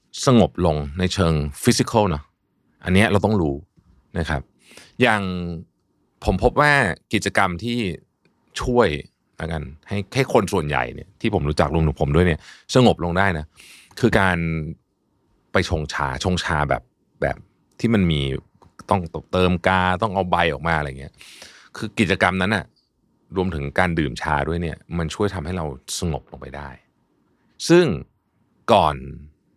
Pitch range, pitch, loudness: 75-100 Hz, 90 Hz, -21 LUFS